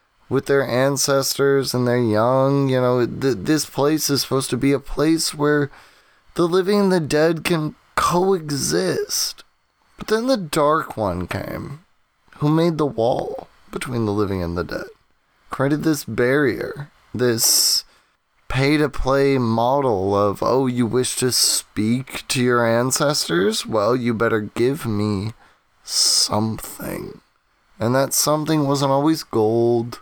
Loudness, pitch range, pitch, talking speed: -19 LUFS, 115-150 Hz, 135 Hz, 140 wpm